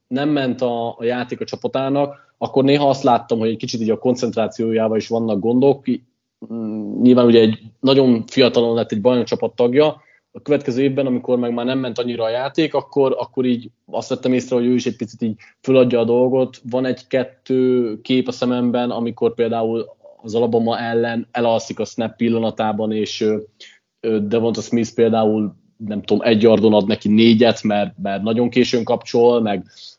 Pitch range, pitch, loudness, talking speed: 115-130 Hz, 120 Hz, -18 LUFS, 170 wpm